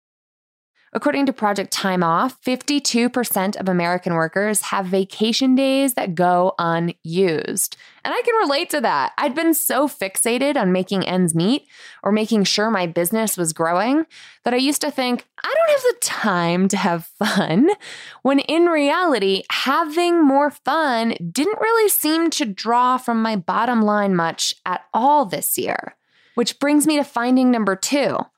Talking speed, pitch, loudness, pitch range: 160 wpm, 240 Hz, -19 LUFS, 195-290 Hz